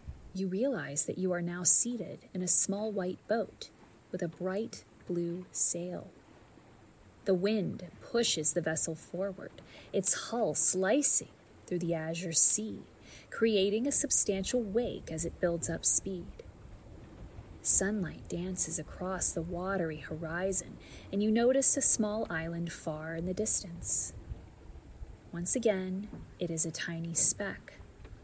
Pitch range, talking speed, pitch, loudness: 165-205 Hz, 130 wpm, 180 Hz, -18 LUFS